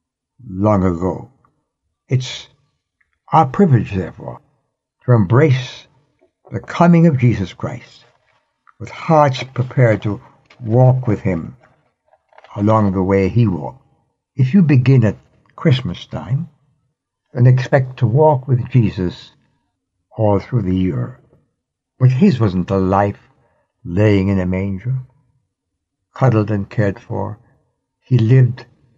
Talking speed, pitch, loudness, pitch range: 115 wpm, 120 Hz, -16 LUFS, 95-130 Hz